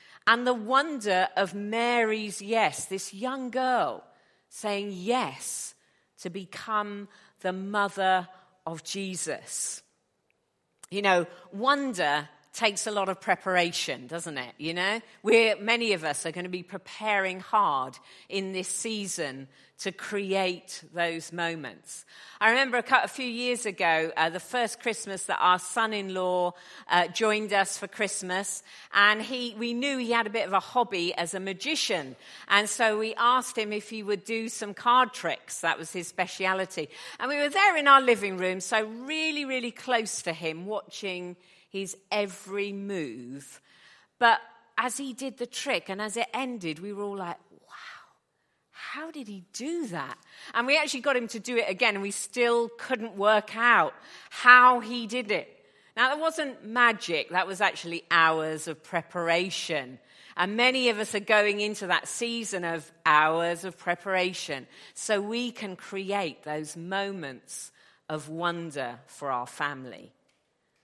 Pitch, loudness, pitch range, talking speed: 200 Hz, -27 LUFS, 180-235 Hz, 160 wpm